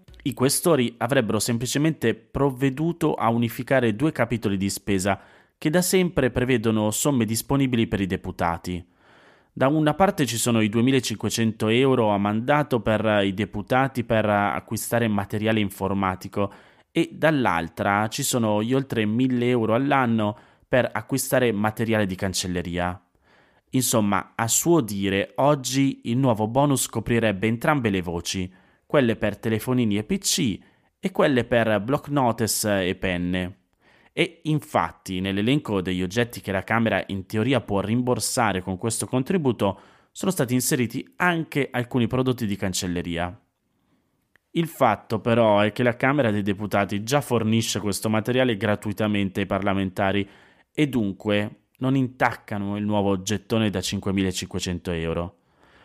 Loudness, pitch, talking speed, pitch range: -23 LUFS, 110 Hz, 135 wpm, 100-130 Hz